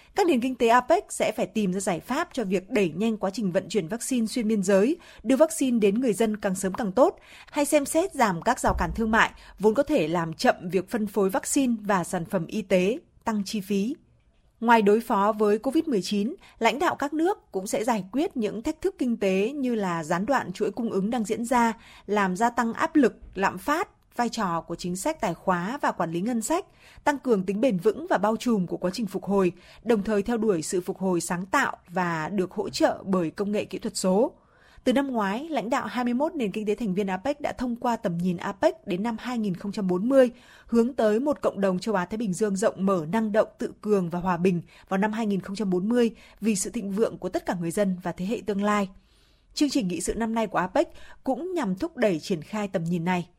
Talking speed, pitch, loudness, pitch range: 235 wpm, 215 Hz, -26 LUFS, 195-250 Hz